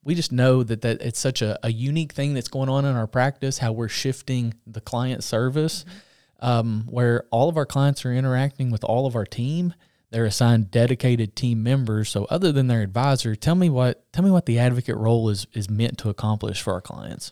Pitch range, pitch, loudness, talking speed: 115-135 Hz, 125 Hz, -23 LUFS, 220 wpm